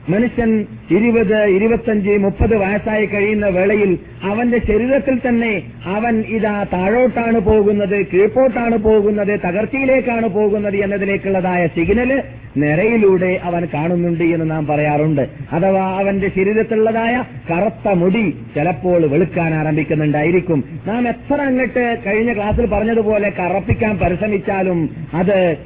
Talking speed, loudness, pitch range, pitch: 100 wpm, -16 LUFS, 175-220 Hz, 200 Hz